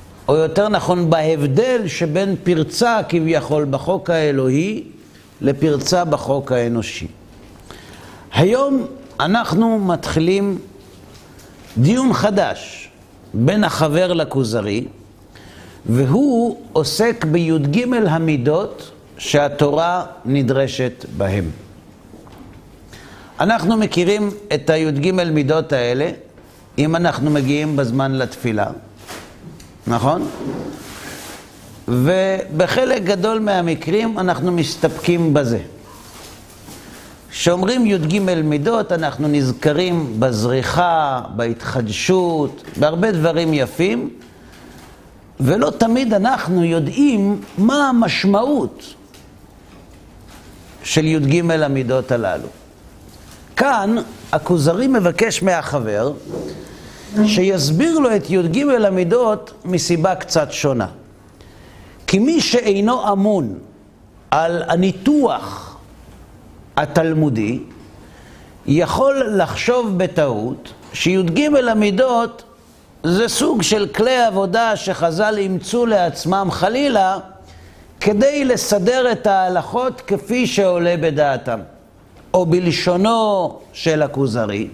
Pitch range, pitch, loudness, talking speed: 130-205 Hz, 165 Hz, -17 LUFS, 75 wpm